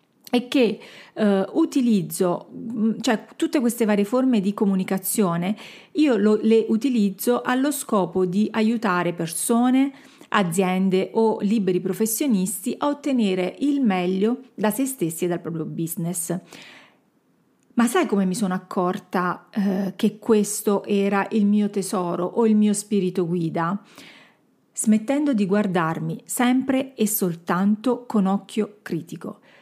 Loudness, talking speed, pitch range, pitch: -22 LUFS, 125 wpm, 185-235 Hz, 210 Hz